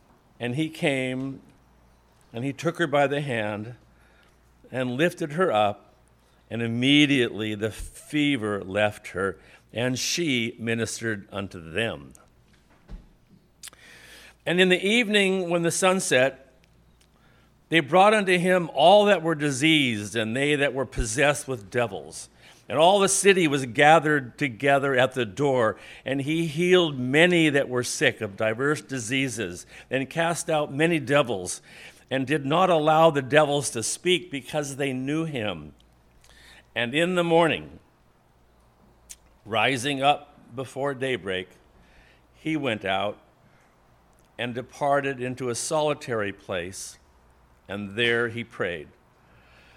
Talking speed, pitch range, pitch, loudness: 130 wpm, 110-155 Hz, 130 Hz, -24 LUFS